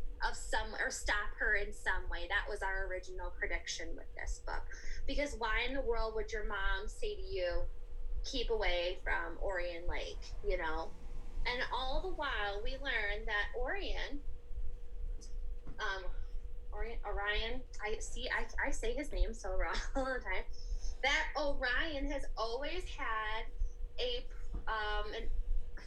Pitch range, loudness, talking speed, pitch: 195-275 Hz, -39 LUFS, 150 wpm, 220 Hz